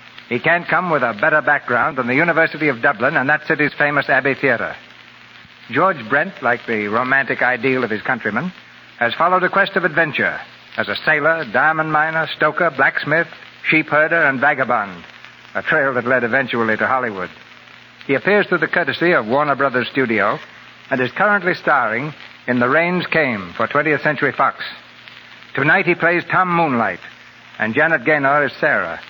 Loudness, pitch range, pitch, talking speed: -17 LUFS, 130-165 Hz, 150 Hz, 165 wpm